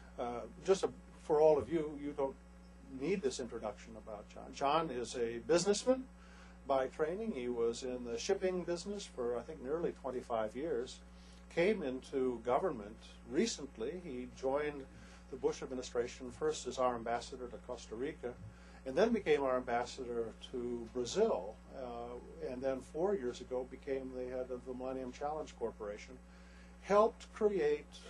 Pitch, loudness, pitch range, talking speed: 125 Hz, -38 LUFS, 115-155 Hz, 150 wpm